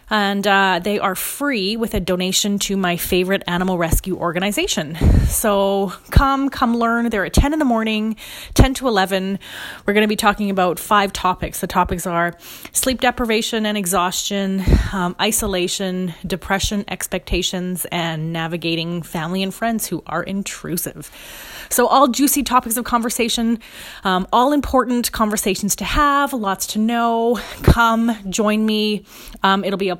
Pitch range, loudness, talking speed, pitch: 185-230 Hz, -18 LUFS, 150 wpm, 200 Hz